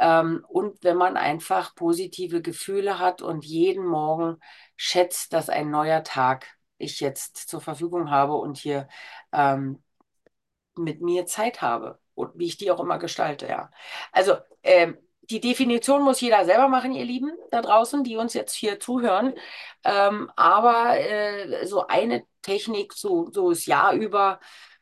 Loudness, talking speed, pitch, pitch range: -23 LUFS, 150 wpm, 200 Hz, 165-250 Hz